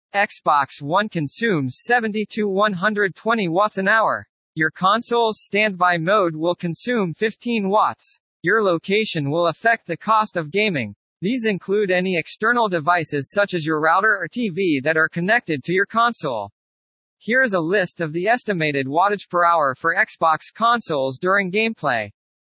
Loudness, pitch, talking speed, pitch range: -20 LUFS, 190 Hz, 150 wpm, 165-215 Hz